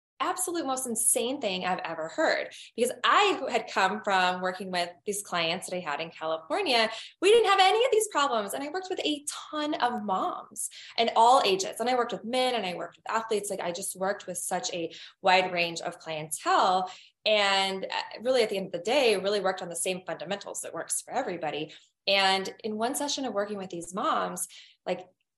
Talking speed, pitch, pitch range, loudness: 210 wpm, 200 Hz, 180-255 Hz, -28 LUFS